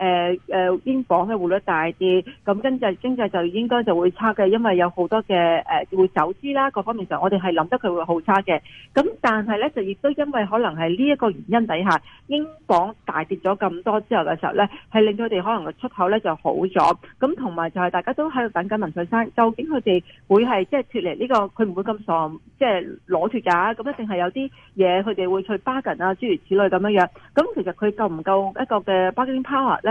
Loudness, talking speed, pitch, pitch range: -21 LUFS, 365 characters per minute, 200 Hz, 180-230 Hz